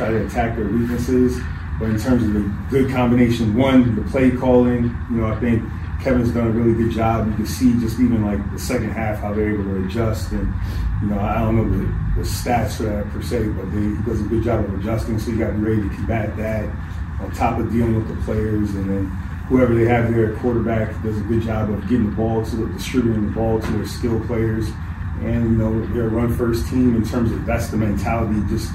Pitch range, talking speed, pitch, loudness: 100-115 Hz, 235 wpm, 110 Hz, -20 LUFS